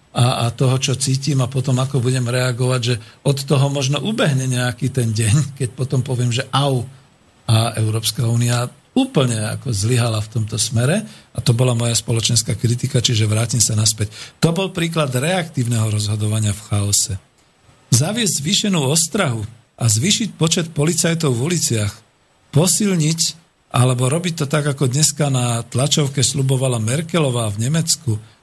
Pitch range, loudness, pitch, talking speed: 115-150 Hz, -18 LUFS, 130 Hz, 150 wpm